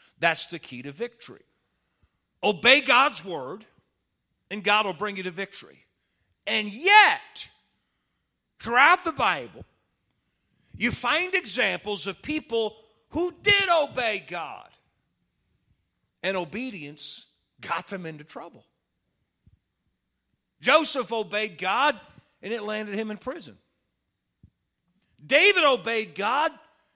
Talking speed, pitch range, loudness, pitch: 105 wpm, 195-305 Hz, -23 LUFS, 220 Hz